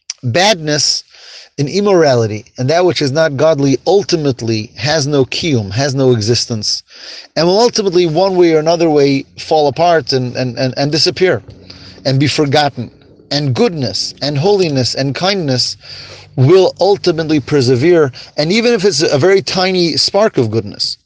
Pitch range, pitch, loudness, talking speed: 125-175 Hz, 145 Hz, -13 LUFS, 150 wpm